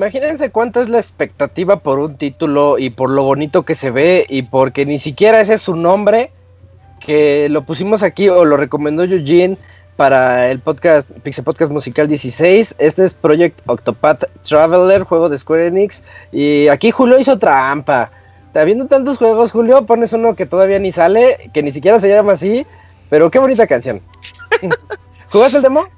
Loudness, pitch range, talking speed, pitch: -12 LUFS, 145-220 Hz, 175 wpm, 175 Hz